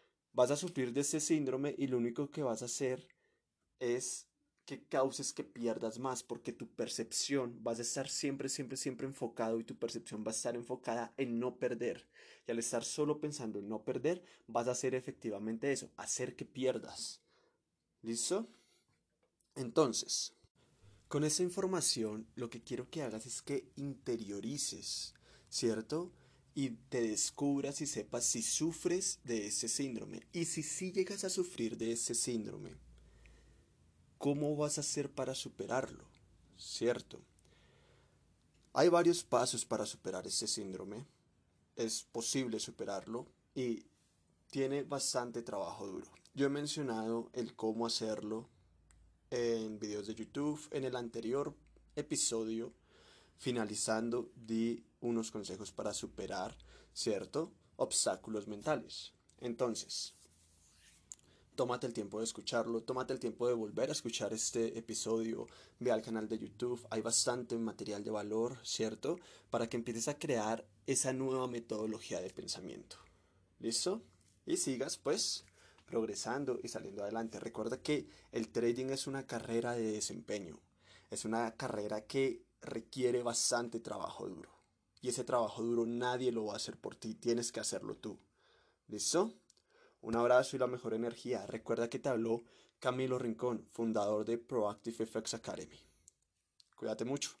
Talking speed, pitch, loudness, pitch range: 140 wpm, 120 Hz, -38 LUFS, 110-130 Hz